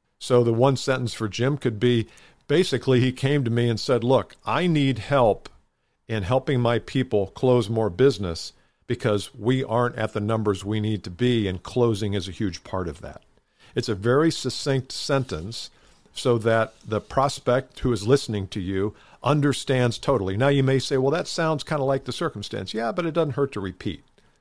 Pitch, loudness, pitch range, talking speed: 120 Hz, -24 LUFS, 105-135 Hz, 195 wpm